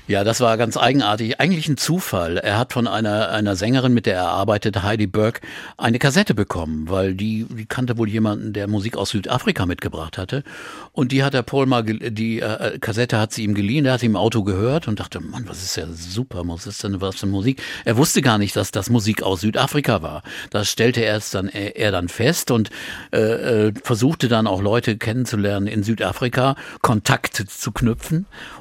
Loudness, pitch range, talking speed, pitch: -20 LUFS, 100-125 Hz, 210 wpm, 110 Hz